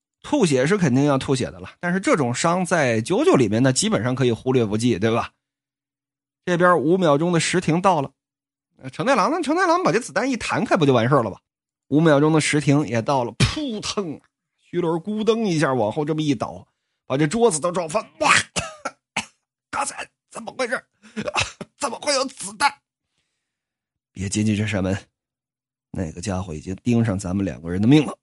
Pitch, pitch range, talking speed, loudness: 140 Hz, 120-175 Hz, 270 characters per minute, -21 LUFS